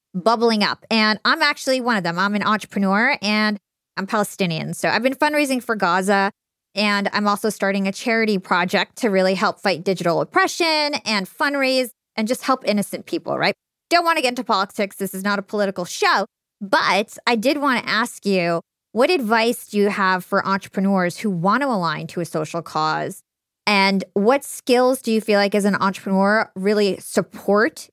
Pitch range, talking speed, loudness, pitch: 195-235 Hz, 185 wpm, -20 LUFS, 205 Hz